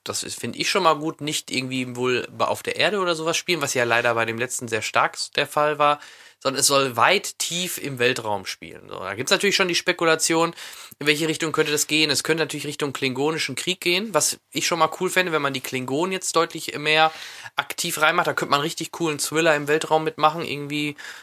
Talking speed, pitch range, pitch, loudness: 225 wpm, 140-165 Hz, 155 Hz, -22 LUFS